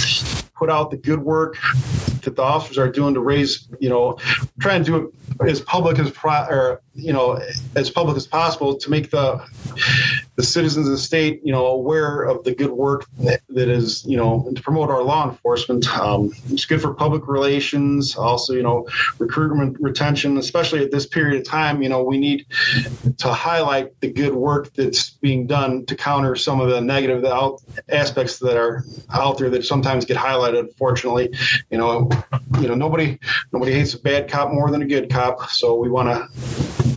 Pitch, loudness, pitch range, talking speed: 135 Hz, -19 LUFS, 125-145 Hz, 190 wpm